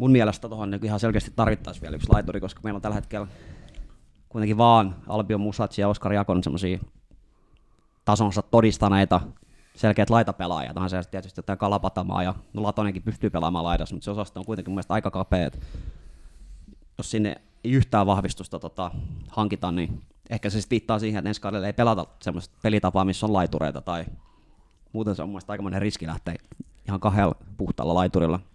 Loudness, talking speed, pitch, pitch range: -25 LUFS, 165 wpm, 100 Hz, 90-105 Hz